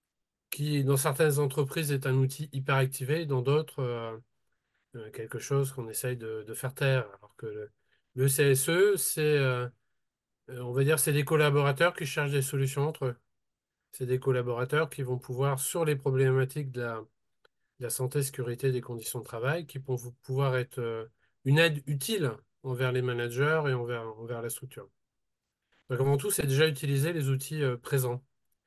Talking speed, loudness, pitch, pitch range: 175 wpm, -29 LUFS, 135 Hz, 125-145 Hz